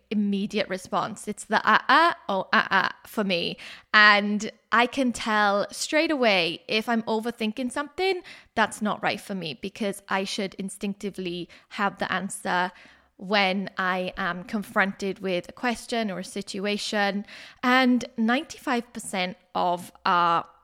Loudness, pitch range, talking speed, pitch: -25 LUFS, 190-230 Hz, 135 wpm, 205 Hz